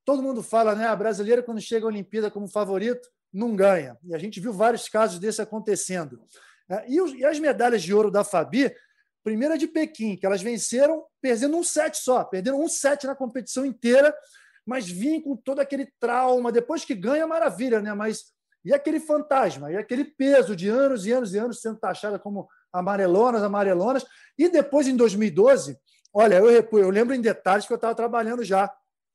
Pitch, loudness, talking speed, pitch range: 235 Hz, -23 LUFS, 190 wpm, 210-275 Hz